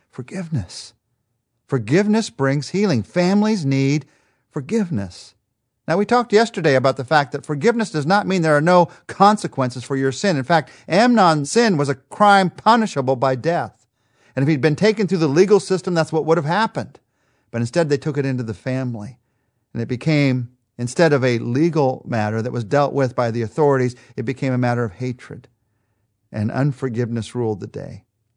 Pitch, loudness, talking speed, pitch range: 140 Hz, -19 LUFS, 180 wpm, 120-170 Hz